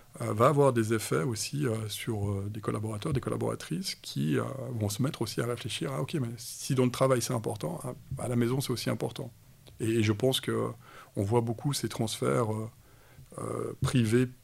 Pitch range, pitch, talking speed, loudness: 115-130 Hz, 120 Hz, 175 wpm, -31 LUFS